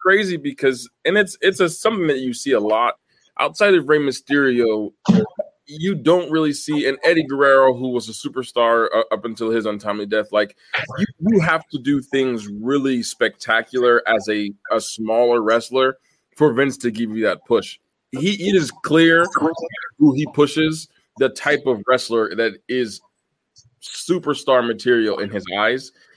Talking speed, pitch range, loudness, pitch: 165 wpm, 115-155 Hz, -19 LUFS, 135 Hz